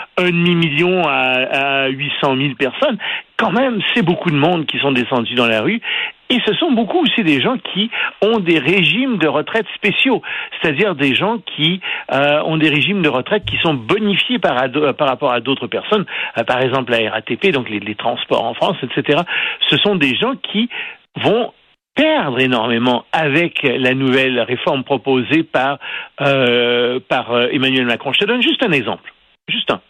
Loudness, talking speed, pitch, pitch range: -15 LUFS, 185 wpm, 145 Hz, 130-195 Hz